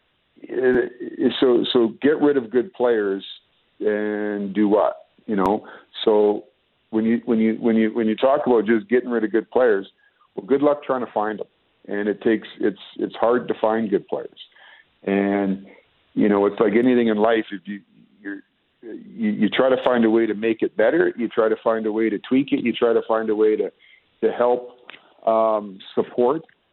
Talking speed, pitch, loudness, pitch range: 200 wpm, 115 Hz, -21 LUFS, 105-130 Hz